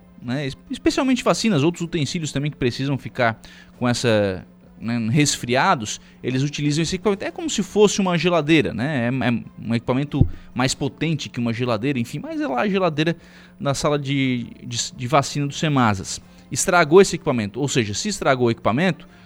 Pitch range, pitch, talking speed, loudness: 120-170 Hz, 140 Hz, 175 wpm, -21 LUFS